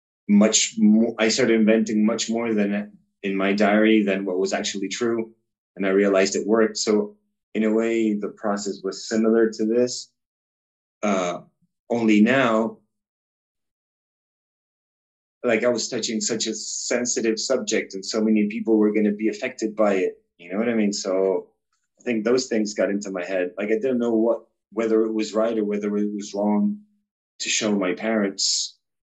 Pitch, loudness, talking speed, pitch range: 110 Hz, -22 LUFS, 175 wpm, 100-115 Hz